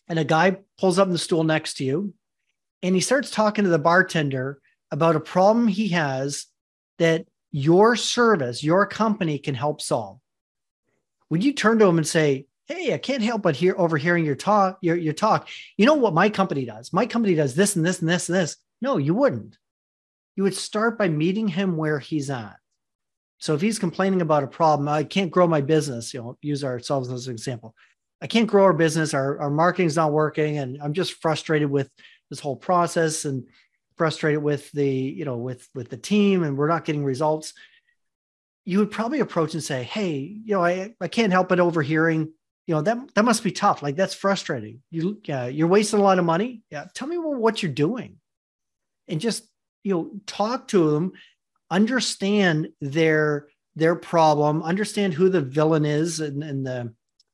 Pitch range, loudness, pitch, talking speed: 150-195 Hz, -22 LUFS, 165 Hz, 200 wpm